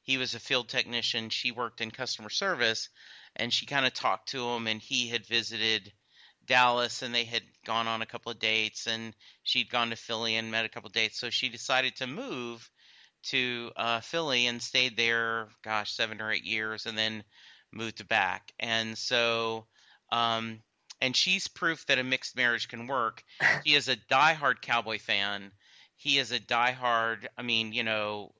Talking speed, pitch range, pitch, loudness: 185 wpm, 110-125 Hz, 115 Hz, -29 LUFS